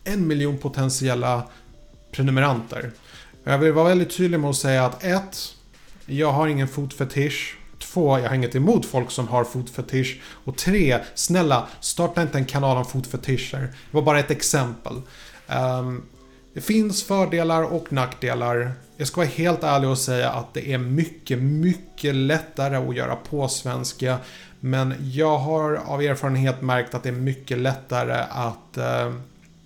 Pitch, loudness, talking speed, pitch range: 135 Hz, -23 LUFS, 155 wpm, 125-155 Hz